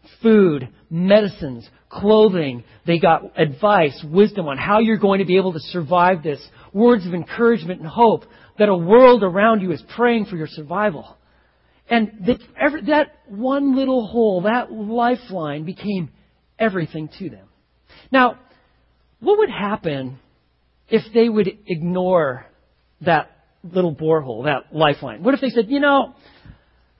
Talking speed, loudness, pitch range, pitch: 140 wpm, -18 LUFS, 160-230 Hz, 190 Hz